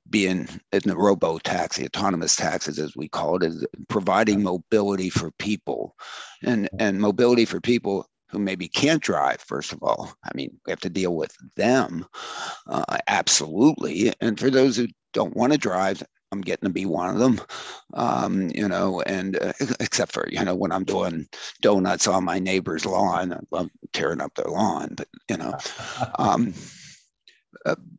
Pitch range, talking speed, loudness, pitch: 90-110 Hz, 175 wpm, -24 LUFS, 100 Hz